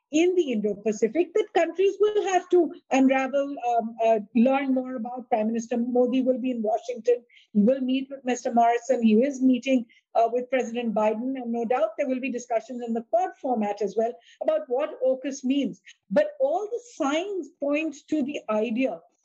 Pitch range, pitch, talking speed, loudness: 235-295 Hz, 260 Hz, 185 wpm, -25 LUFS